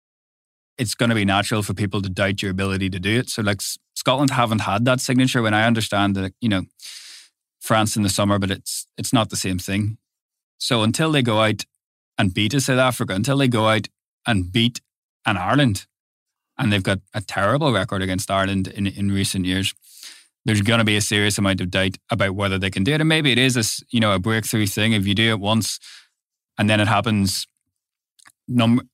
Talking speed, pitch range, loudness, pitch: 215 wpm, 100-120 Hz, -20 LUFS, 105 Hz